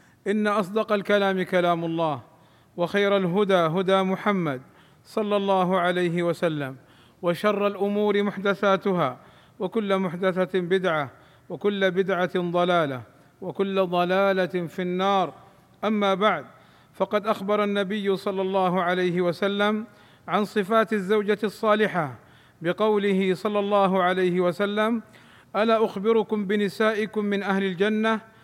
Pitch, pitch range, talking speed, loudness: 195 Hz, 180-210 Hz, 105 wpm, -24 LUFS